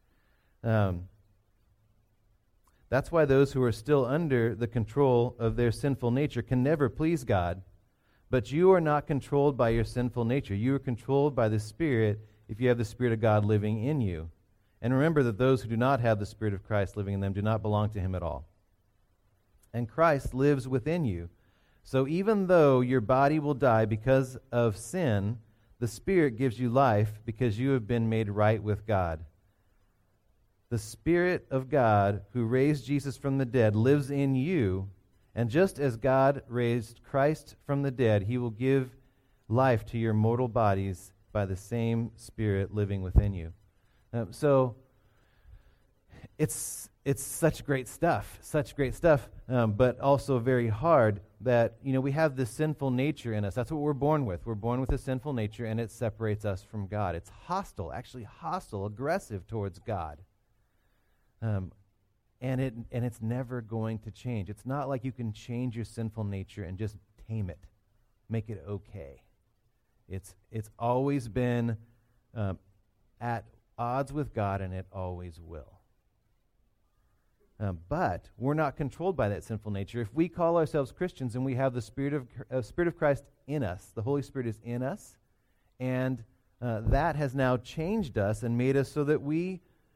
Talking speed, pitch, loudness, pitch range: 175 wpm, 115 Hz, -29 LUFS, 105-135 Hz